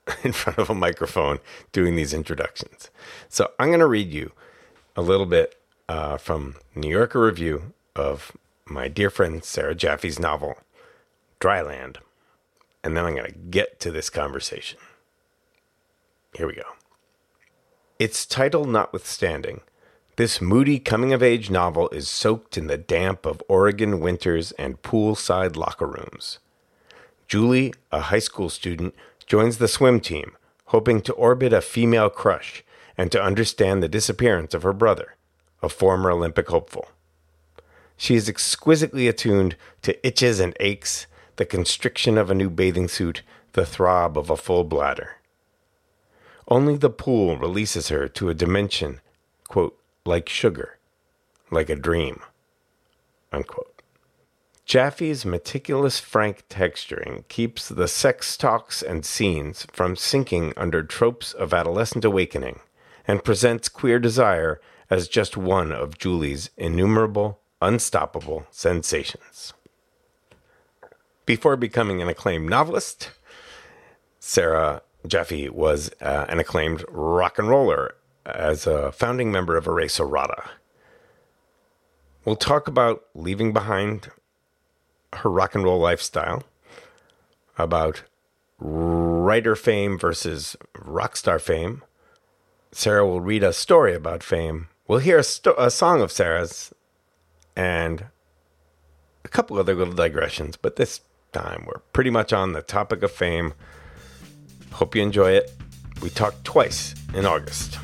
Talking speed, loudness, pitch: 130 wpm, -22 LUFS, 110 Hz